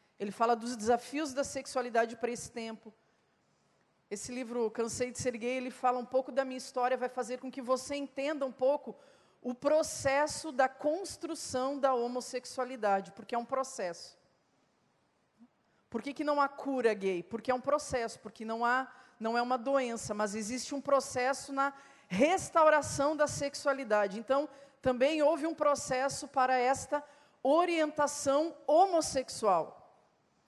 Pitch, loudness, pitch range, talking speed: 260 Hz, -32 LUFS, 240-280 Hz, 150 wpm